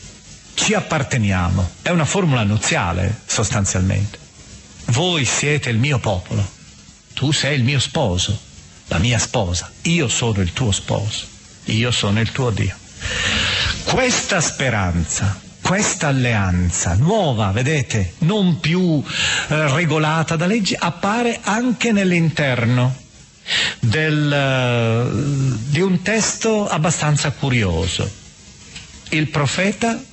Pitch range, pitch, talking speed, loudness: 105-160 Hz, 130 Hz, 110 wpm, -18 LUFS